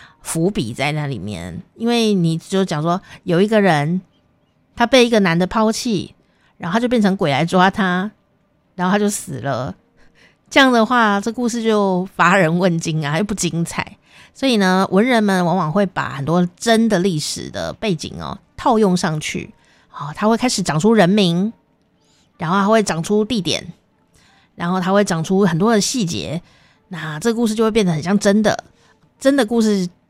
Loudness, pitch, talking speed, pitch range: -17 LUFS, 195 Hz, 250 characters per minute, 170-220 Hz